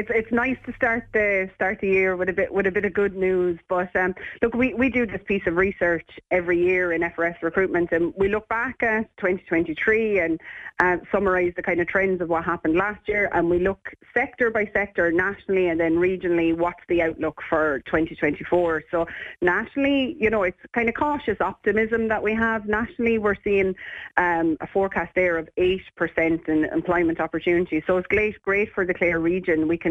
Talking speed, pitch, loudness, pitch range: 205 wpm, 185 Hz, -23 LUFS, 170-210 Hz